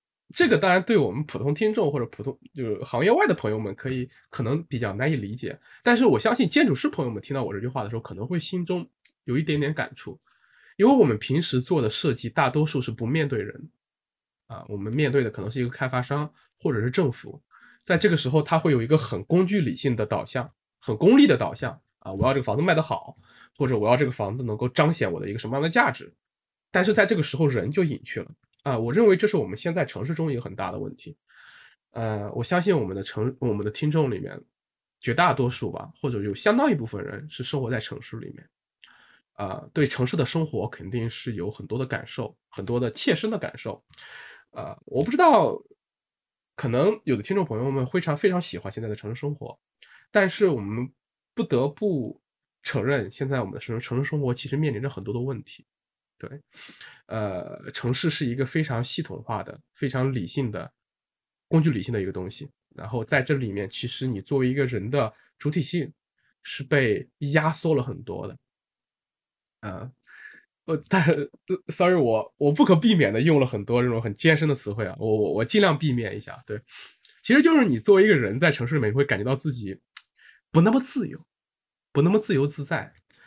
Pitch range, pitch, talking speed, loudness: 120-165 Hz, 140 Hz, 315 characters per minute, -24 LUFS